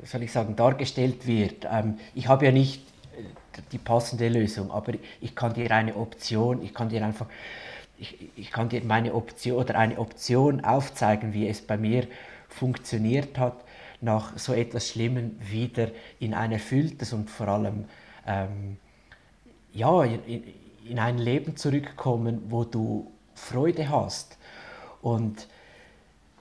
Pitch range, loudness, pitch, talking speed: 110-125 Hz, -27 LUFS, 115 Hz, 140 wpm